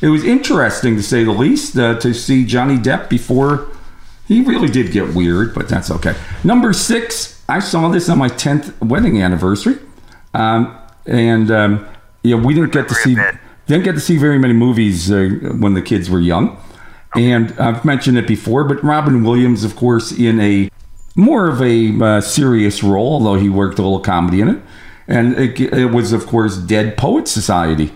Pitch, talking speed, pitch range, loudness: 115 Hz, 190 wpm, 105-135 Hz, -14 LUFS